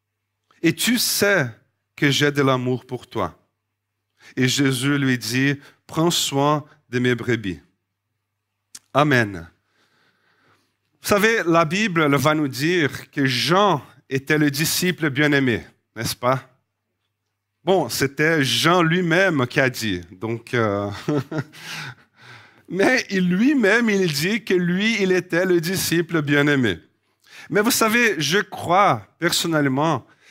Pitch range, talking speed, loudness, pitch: 115-170 Hz, 120 wpm, -20 LUFS, 140 Hz